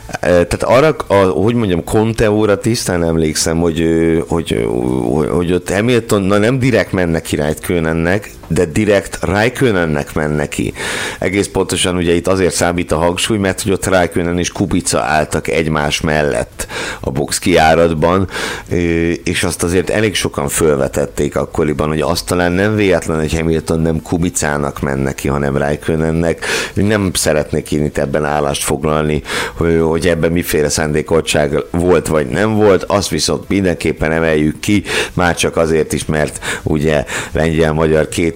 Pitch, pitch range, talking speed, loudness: 85 Hz, 75-95 Hz, 145 wpm, -14 LUFS